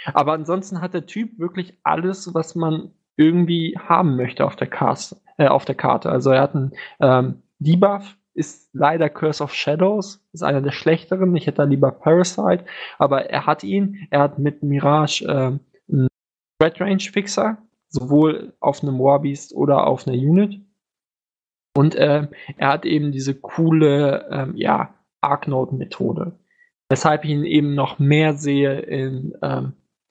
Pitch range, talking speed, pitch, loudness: 140-180 Hz, 150 wpm, 155 Hz, -19 LUFS